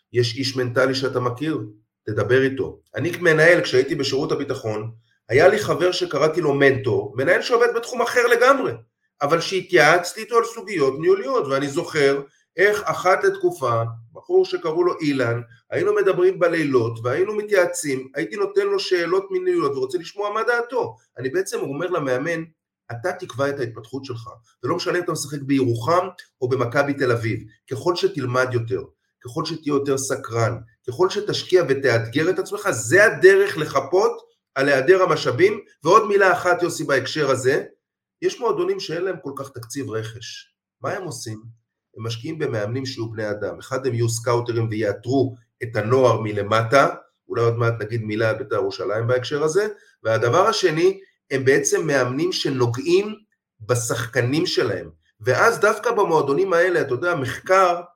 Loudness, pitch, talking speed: -20 LUFS, 155 Hz, 150 wpm